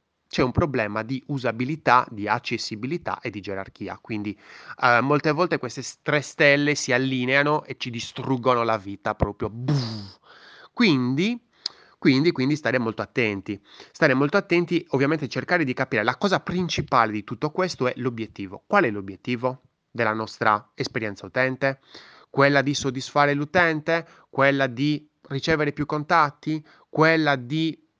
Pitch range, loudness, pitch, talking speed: 115-150 Hz, -23 LUFS, 130 Hz, 135 wpm